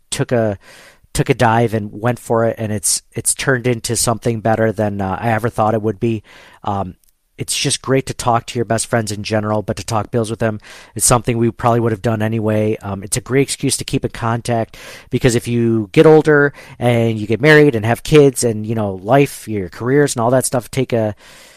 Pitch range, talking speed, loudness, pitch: 110-125 Hz, 230 wpm, -16 LUFS, 115 Hz